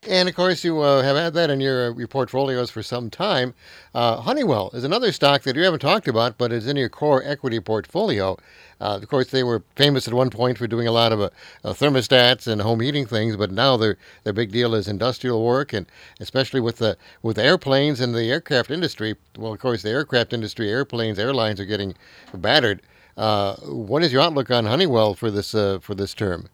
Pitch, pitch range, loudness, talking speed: 120 Hz, 110-135 Hz, -21 LUFS, 215 wpm